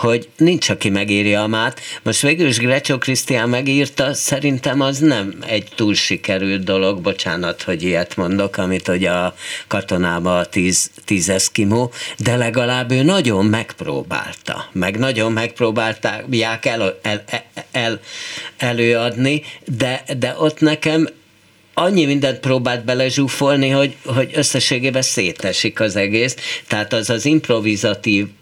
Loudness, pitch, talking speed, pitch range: -17 LUFS, 120 Hz, 130 wpm, 105-135 Hz